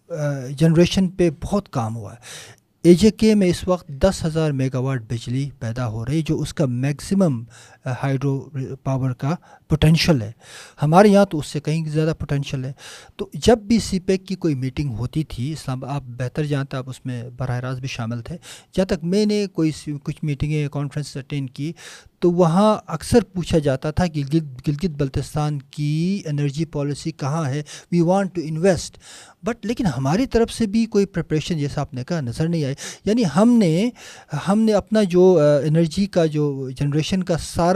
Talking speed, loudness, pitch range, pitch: 185 wpm, -21 LUFS, 140-180 Hz, 155 Hz